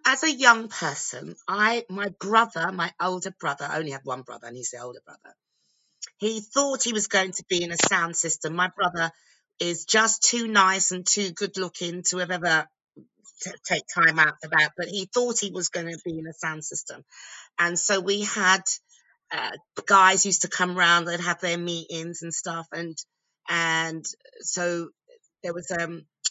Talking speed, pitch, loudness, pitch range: 190 wpm, 180 Hz, -24 LUFS, 165-200 Hz